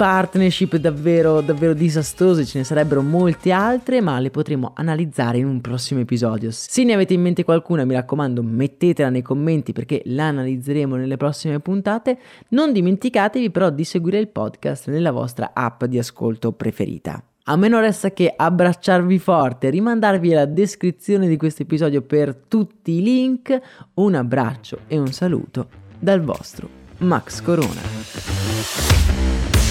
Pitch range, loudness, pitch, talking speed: 130-185 Hz, -19 LUFS, 155 Hz, 145 wpm